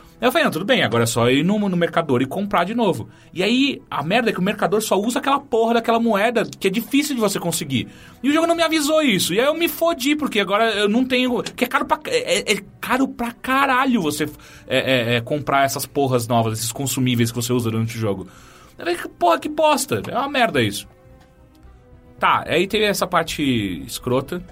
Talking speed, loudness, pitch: 220 wpm, -19 LUFS, 200 Hz